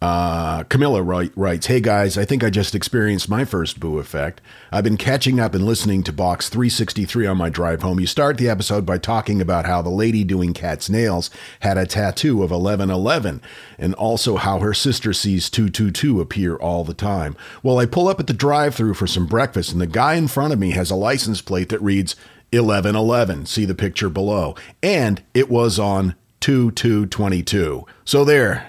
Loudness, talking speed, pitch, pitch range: -19 LUFS, 195 wpm, 100 Hz, 90-115 Hz